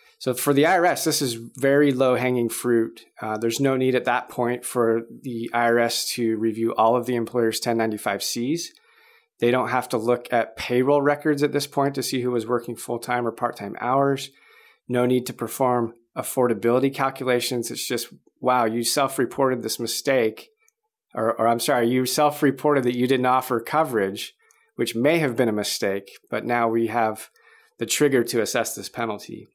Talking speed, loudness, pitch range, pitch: 185 wpm, -23 LUFS, 115-140 Hz, 125 Hz